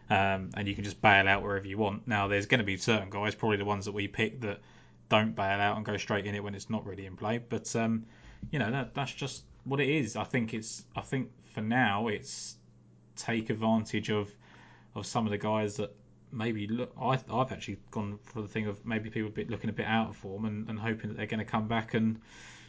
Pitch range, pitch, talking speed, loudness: 105-115 Hz, 110 Hz, 245 wpm, -32 LUFS